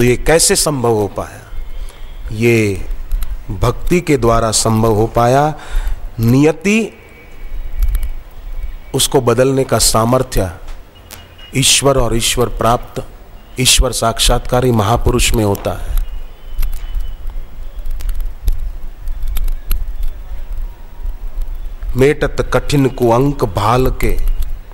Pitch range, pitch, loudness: 80-125 Hz, 110 Hz, -14 LUFS